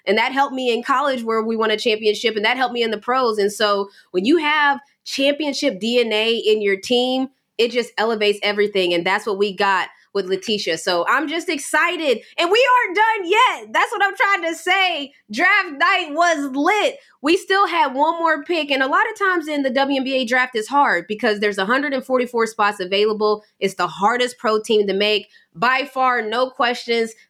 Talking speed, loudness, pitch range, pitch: 200 wpm, -18 LUFS, 215-305 Hz, 250 Hz